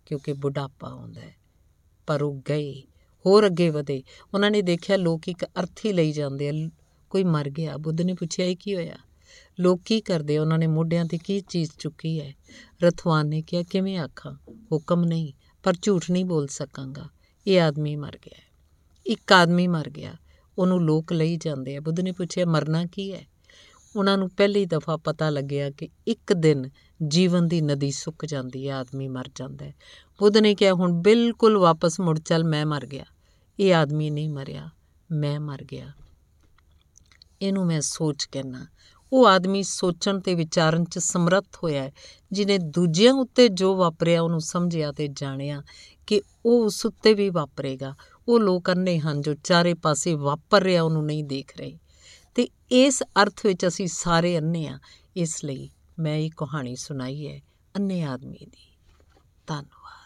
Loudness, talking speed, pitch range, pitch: -23 LUFS, 170 wpm, 145-185 Hz, 160 Hz